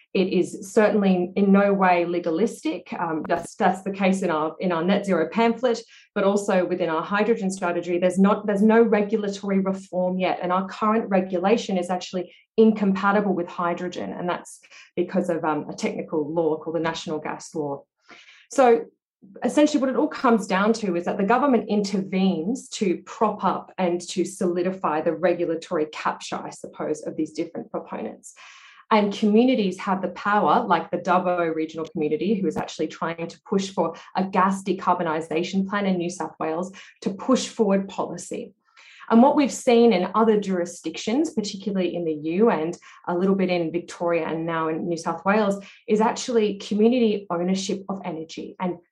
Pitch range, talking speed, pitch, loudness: 175-210 Hz, 175 wpm, 185 Hz, -23 LUFS